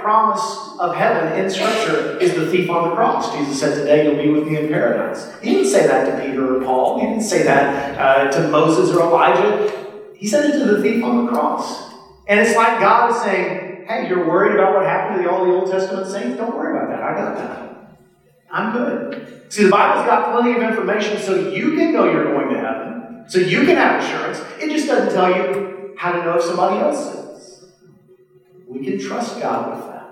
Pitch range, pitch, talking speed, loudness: 170-225 Hz, 190 Hz, 220 wpm, -17 LUFS